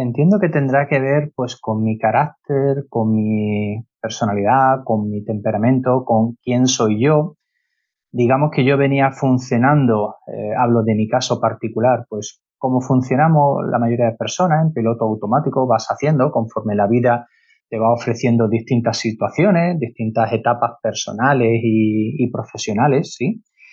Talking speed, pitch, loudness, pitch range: 145 wpm, 120 Hz, -17 LUFS, 110-135 Hz